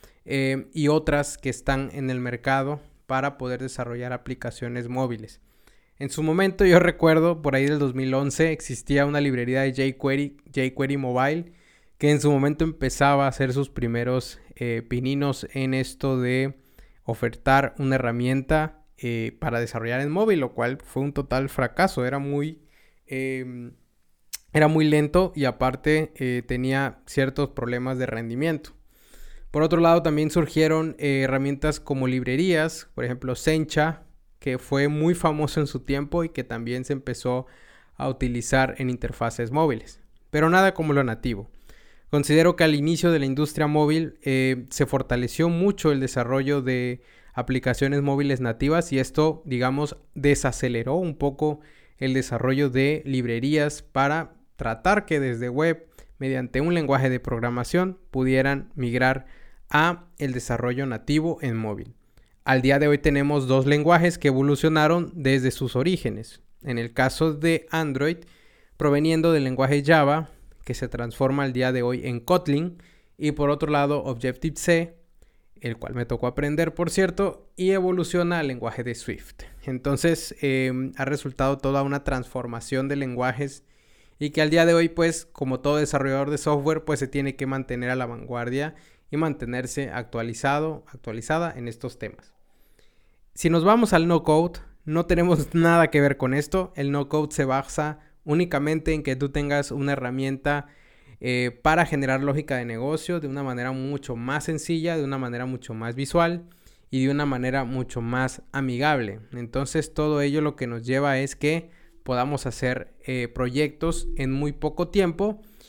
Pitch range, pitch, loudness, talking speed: 130-155 Hz, 140 Hz, -24 LUFS, 155 wpm